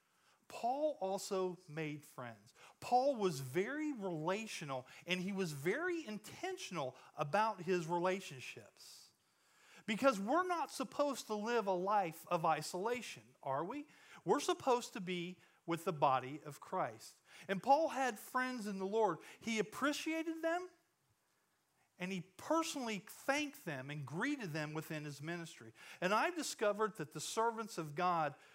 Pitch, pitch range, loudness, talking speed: 195 Hz, 165-260 Hz, -39 LUFS, 140 wpm